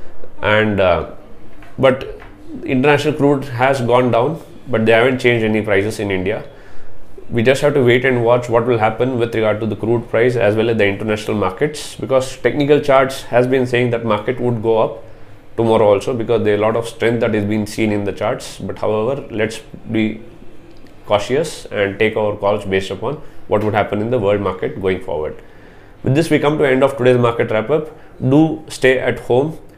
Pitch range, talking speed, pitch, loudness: 105-130 Hz, 200 wpm, 115 Hz, -16 LUFS